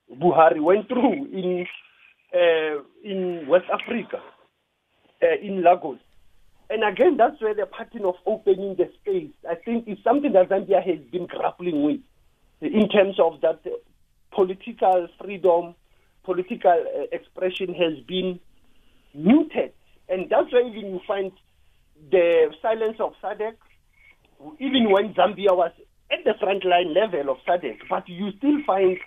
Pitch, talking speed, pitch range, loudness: 195 Hz, 140 wpm, 180-235 Hz, -23 LUFS